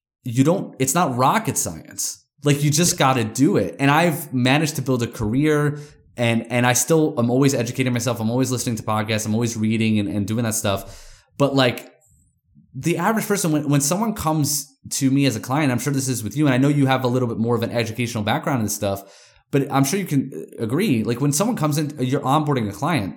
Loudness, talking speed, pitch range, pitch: -20 LUFS, 235 wpm, 115-145 Hz, 130 Hz